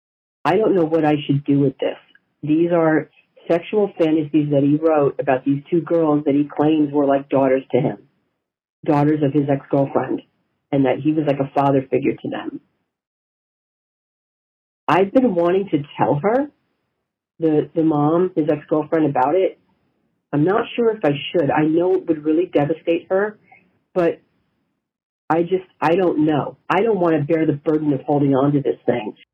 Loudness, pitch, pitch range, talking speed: -19 LUFS, 155 Hz, 145-170 Hz, 180 wpm